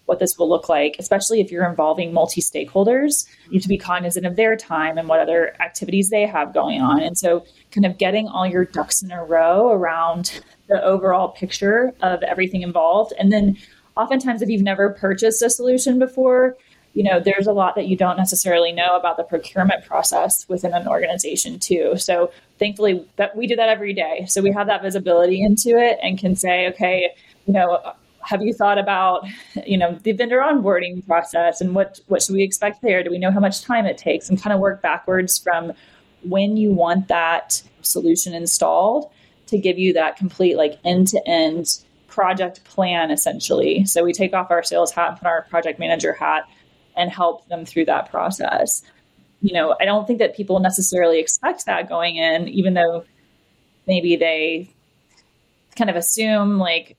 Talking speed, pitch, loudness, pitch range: 190 wpm, 185 Hz, -19 LUFS, 175-210 Hz